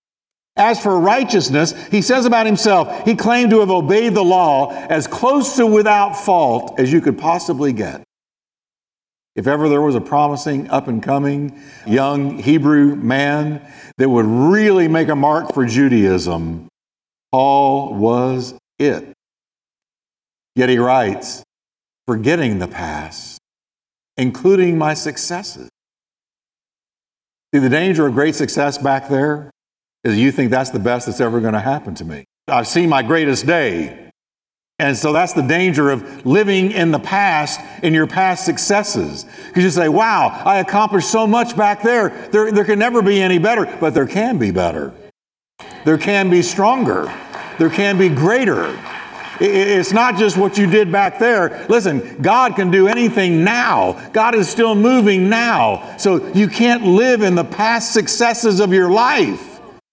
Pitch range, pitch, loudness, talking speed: 140-205 Hz, 170 Hz, -15 LUFS, 155 wpm